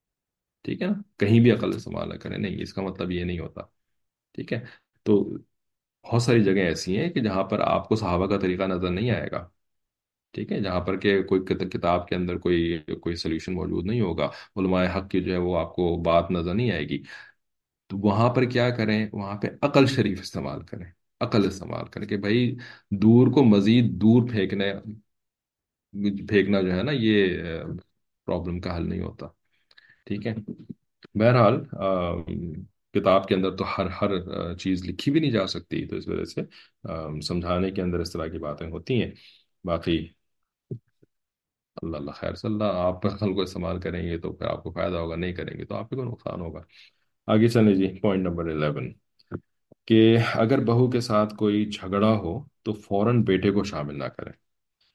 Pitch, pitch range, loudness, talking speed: 100 Hz, 90-110 Hz, -25 LUFS, 185 wpm